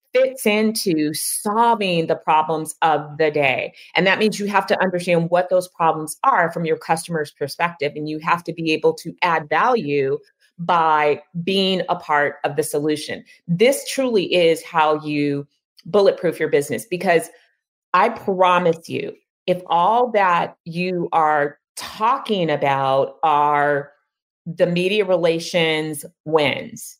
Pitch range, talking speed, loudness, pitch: 155-195 Hz, 140 wpm, -19 LUFS, 170 Hz